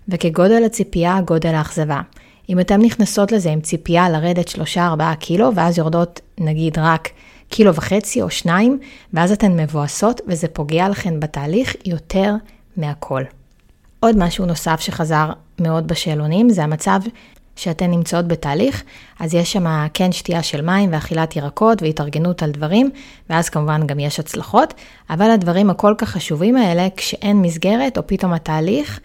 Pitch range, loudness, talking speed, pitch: 160-200 Hz, -17 LUFS, 145 wpm, 175 Hz